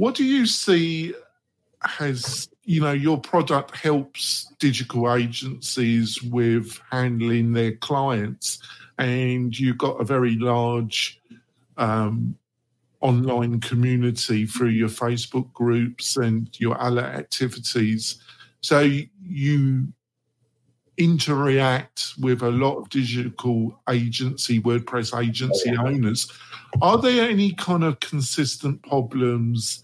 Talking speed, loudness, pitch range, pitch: 105 wpm, -23 LUFS, 120-140 Hz, 125 Hz